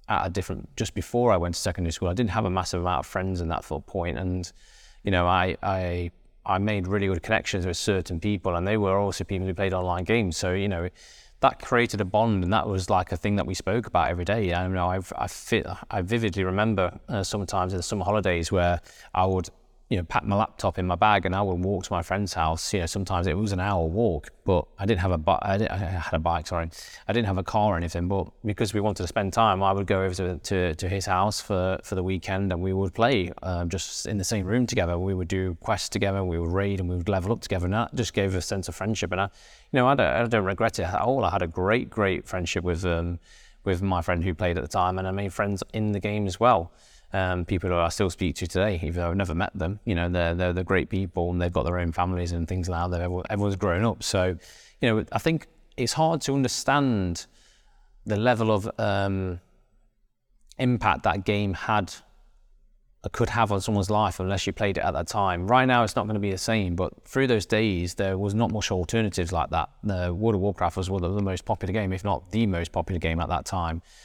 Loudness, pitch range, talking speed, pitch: -26 LUFS, 90-105 Hz, 255 wpm, 95 Hz